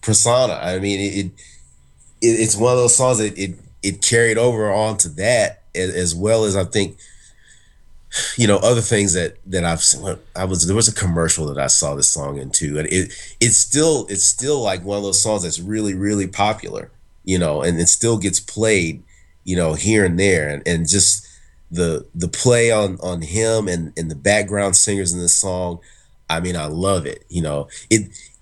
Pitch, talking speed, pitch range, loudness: 95 Hz, 205 wpm, 85-110 Hz, -17 LUFS